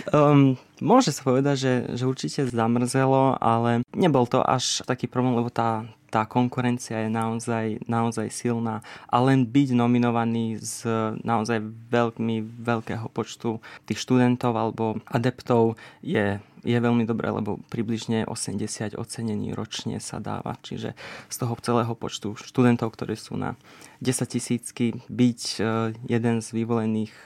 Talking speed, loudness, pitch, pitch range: 135 wpm, -25 LUFS, 115 Hz, 115-125 Hz